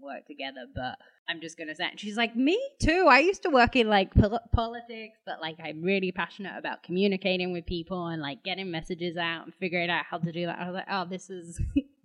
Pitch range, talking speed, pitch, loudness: 170-215 Hz, 240 wpm, 185 Hz, -28 LUFS